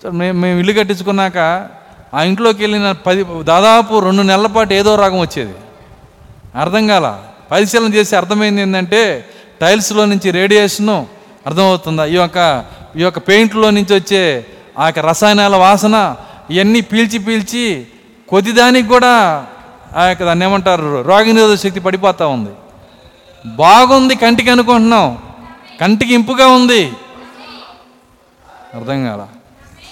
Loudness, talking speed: -11 LUFS, 115 wpm